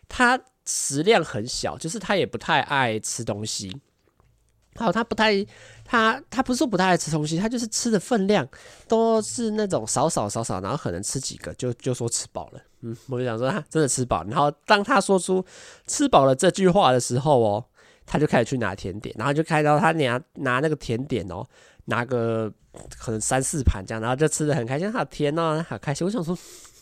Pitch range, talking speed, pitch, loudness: 120-195 Hz, 295 characters per minute, 145 Hz, -23 LUFS